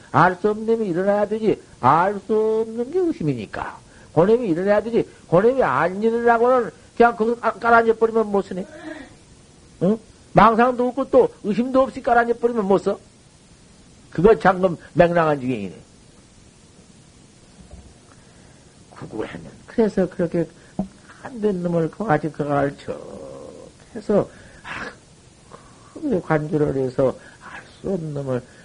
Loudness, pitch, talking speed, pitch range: -20 LUFS, 205 Hz, 245 characters per minute, 165-235 Hz